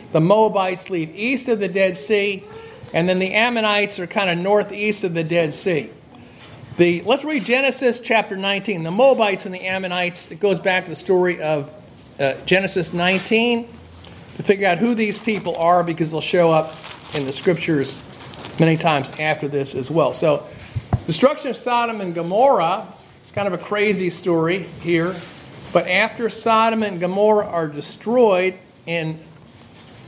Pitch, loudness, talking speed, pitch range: 185 Hz, -19 LUFS, 165 wpm, 165-210 Hz